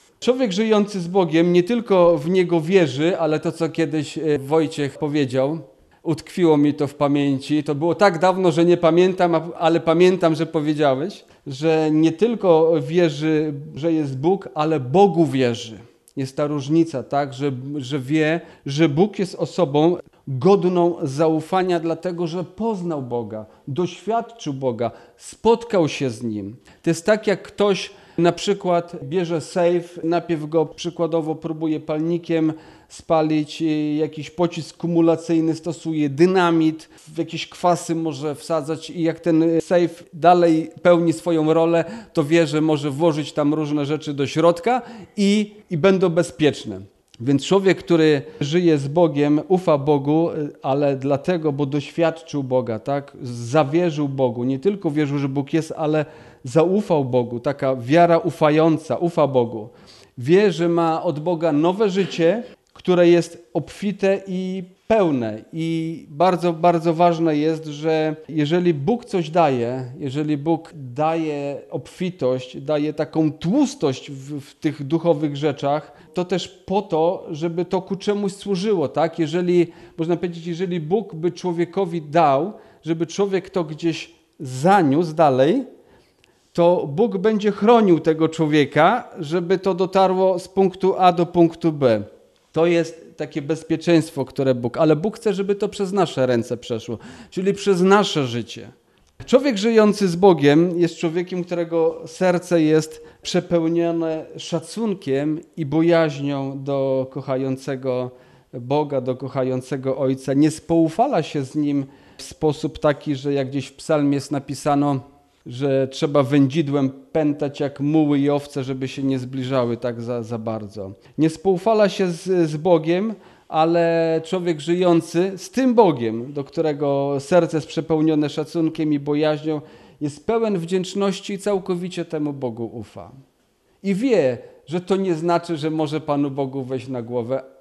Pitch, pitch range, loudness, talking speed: 160 Hz, 145-175 Hz, -20 LUFS, 140 wpm